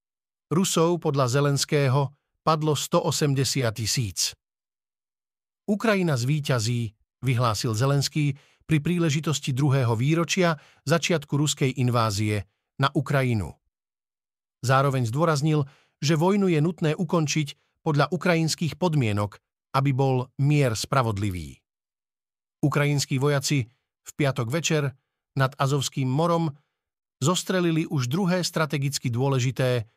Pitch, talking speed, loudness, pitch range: 140 Hz, 90 wpm, -24 LUFS, 130-160 Hz